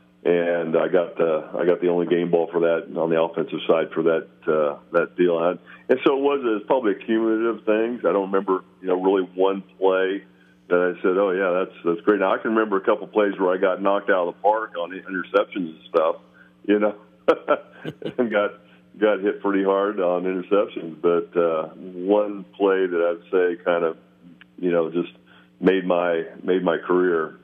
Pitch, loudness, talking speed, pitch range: 90 Hz, -22 LUFS, 205 wpm, 85-95 Hz